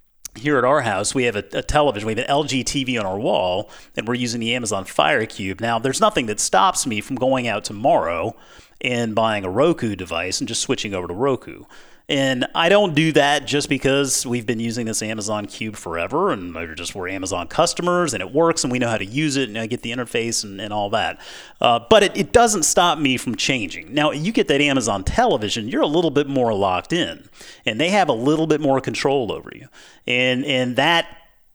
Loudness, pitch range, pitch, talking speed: -20 LUFS, 110-145 Hz, 125 Hz, 225 wpm